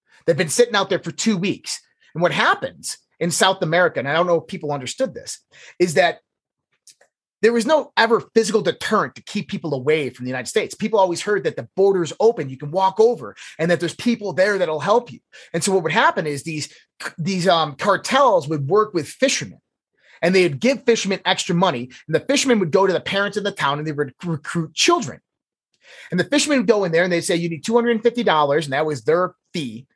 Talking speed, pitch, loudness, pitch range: 225 wpm, 185 Hz, -20 LUFS, 160-225 Hz